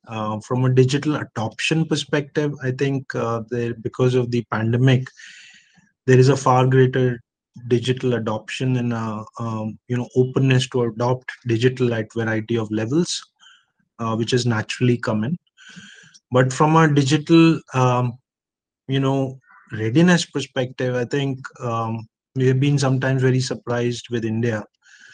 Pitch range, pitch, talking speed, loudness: 115-135 Hz, 125 Hz, 140 wpm, -20 LUFS